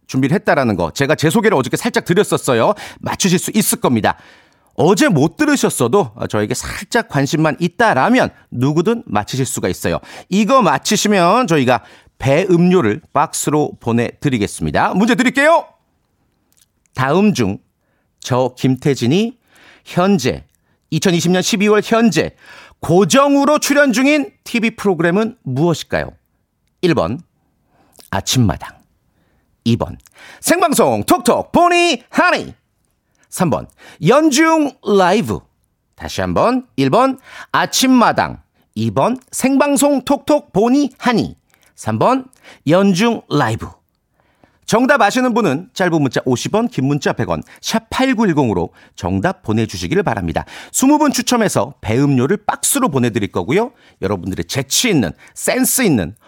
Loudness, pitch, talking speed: -15 LUFS, 200 Hz, 255 characters per minute